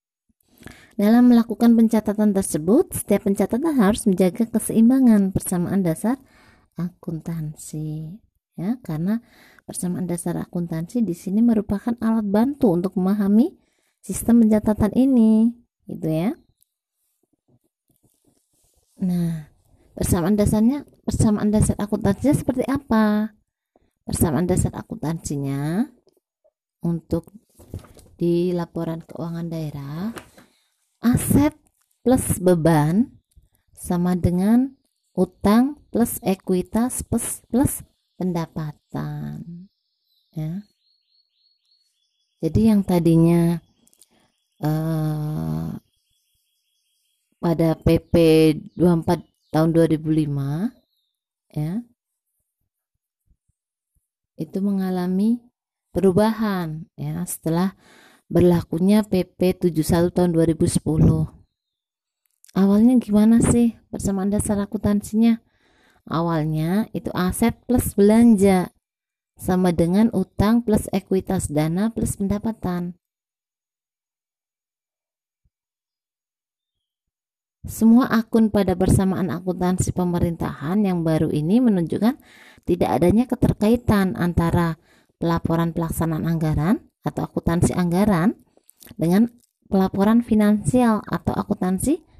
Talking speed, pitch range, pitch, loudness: 80 wpm, 165-220 Hz, 190 Hz, -21 LUFS